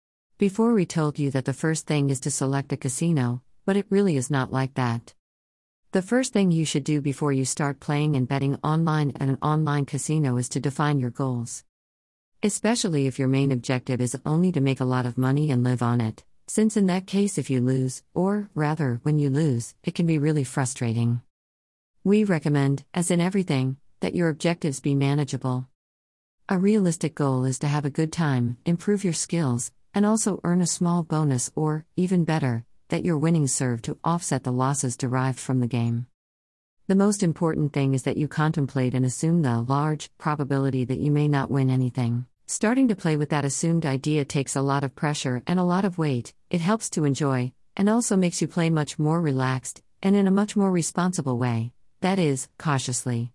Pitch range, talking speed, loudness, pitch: 130-165 Hz, 200 wpm, -24 LUFS, 145 Hz